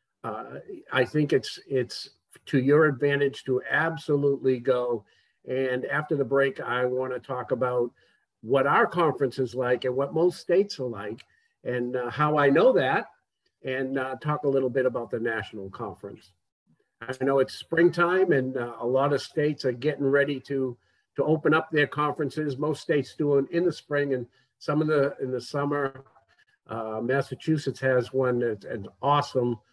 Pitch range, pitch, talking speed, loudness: 125-150 Hz, 135 Hz, 175 wpm, -26 LUFS